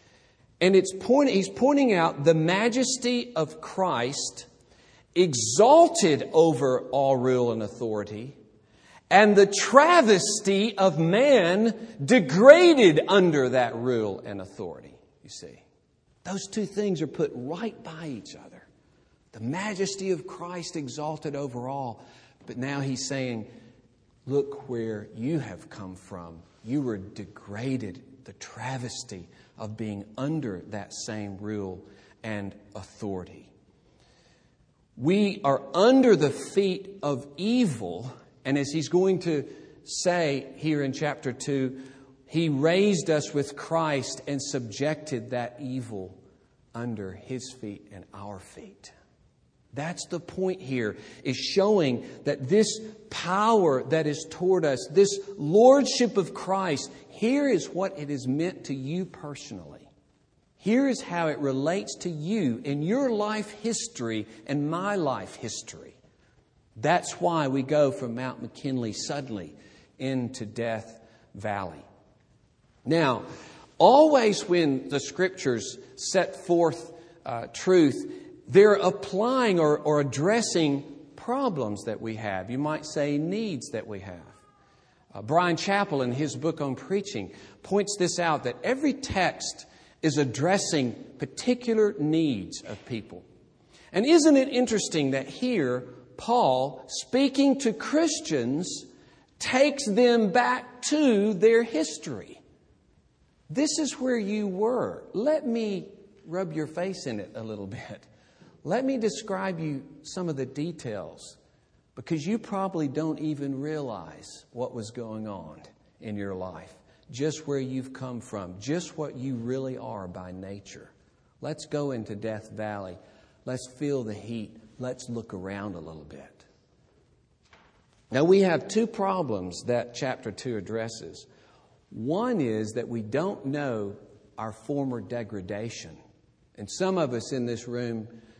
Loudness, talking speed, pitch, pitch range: -26 LUFS, 130 wpm, 140 Hz, 115-190 Hz